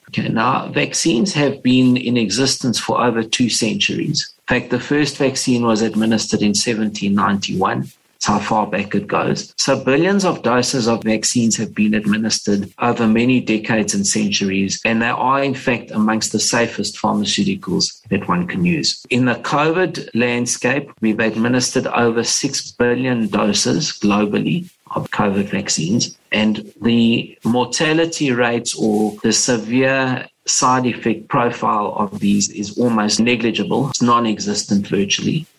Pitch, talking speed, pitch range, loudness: 120 Hz, 145 wpm, 110-135 Hz, -17 LUFS